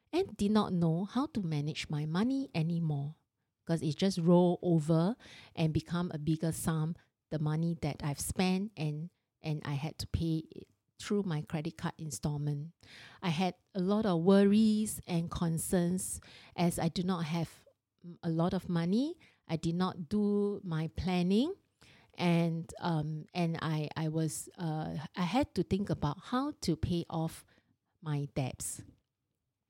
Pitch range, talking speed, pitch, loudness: 155-185 Hz, 160 wpm, 170 Hz, -33 LUFS